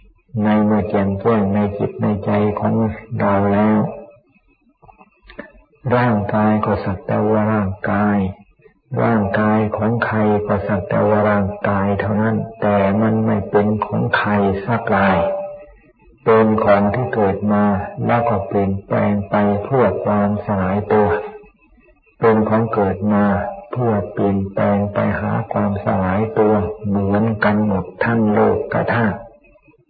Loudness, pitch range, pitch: -17 LUFS, 100-110 Hz, 105 Hz